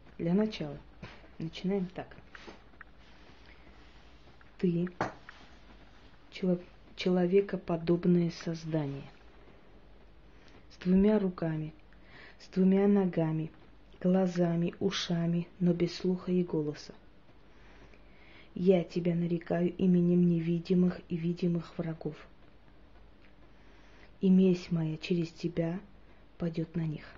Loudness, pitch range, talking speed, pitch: -31 LUFS, 160-185 Hz, 80 wpm, 175 Hz